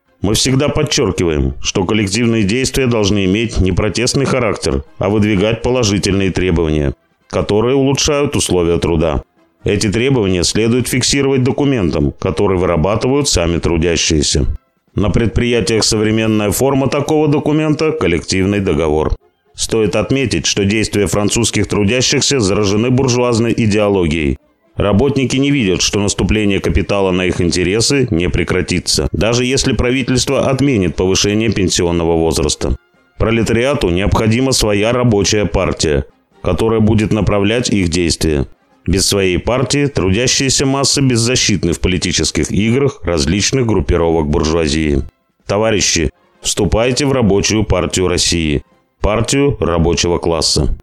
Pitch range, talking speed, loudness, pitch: 90-125 Hz, 110 wpm, -14 LUFS, 105 Hz